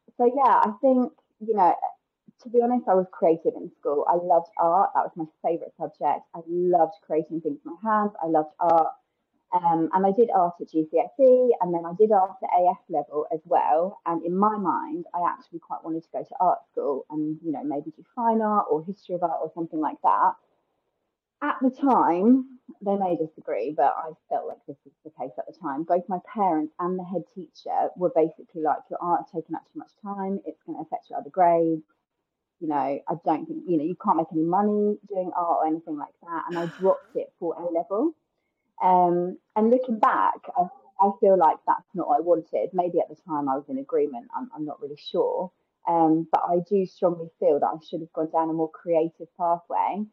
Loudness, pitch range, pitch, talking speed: -25 LUFS, 165-265 Hz, 190 Hz, 220 wpm